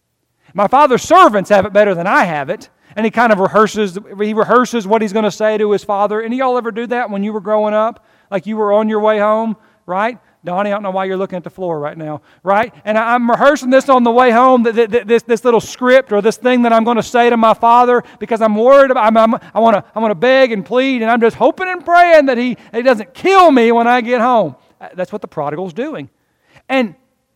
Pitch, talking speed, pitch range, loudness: 225 Hz, 260 wpm, 210-245 Hz, -13 LUFS